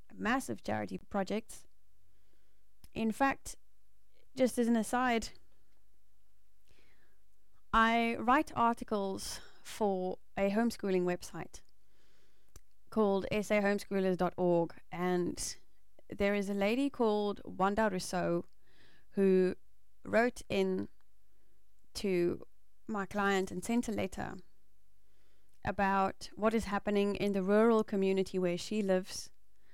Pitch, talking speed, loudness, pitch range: 200 Hz, 95 wpm, -33 LUFS, 185-220 Hz